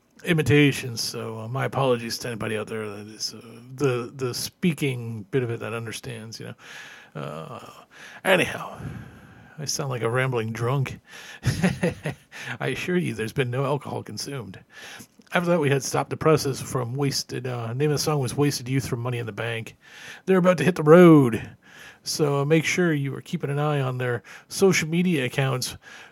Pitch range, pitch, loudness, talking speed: 115-145 Hz, 130 Hz, -24 LUFS, 185 wpm